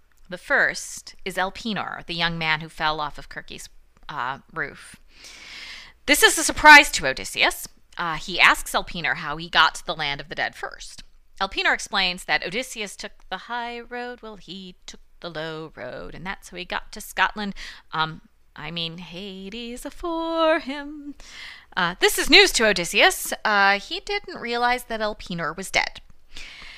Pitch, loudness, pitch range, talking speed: 215 Hz, -21 LUFS, 175-280 Hz, 170 wpm